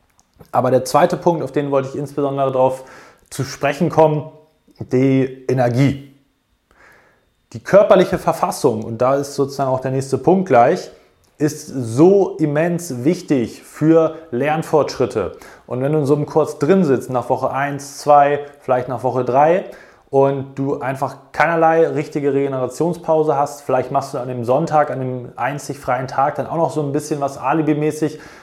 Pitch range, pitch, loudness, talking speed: 130-155 Hz, 140 Hz, -17 LUFS, 160 wpm